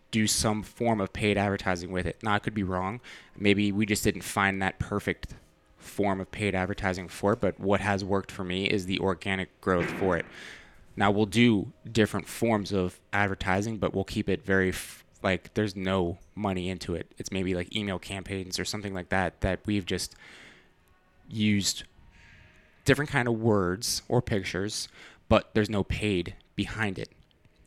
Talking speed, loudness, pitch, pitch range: 180 wpm, -28 LUFS, 100 Hz, 95-105 Hz